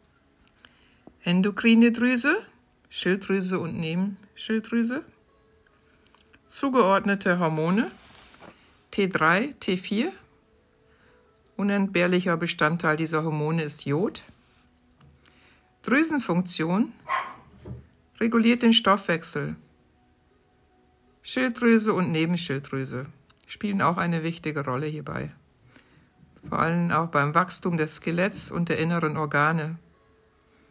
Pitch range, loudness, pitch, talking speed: 155-210 Hz, -25 LUFS, 175 Hz, 75 wpm